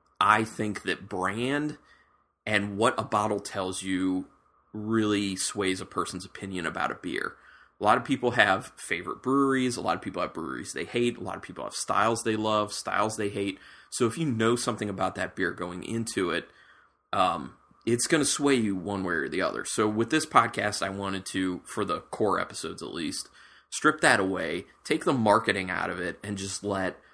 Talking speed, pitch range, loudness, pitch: 200 wpm, 95-120 Hz, -28 LUFS, 105 Hz